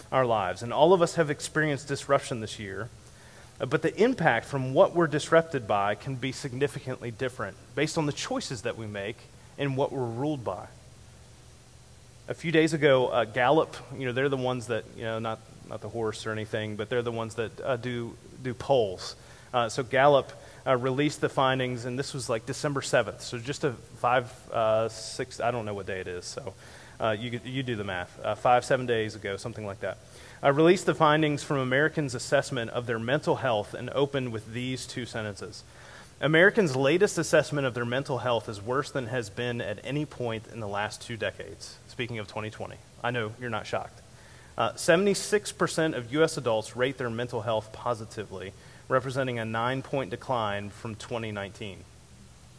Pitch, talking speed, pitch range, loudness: 125 Hz, 195 wpm, 115-140 Hz, -28 LUFS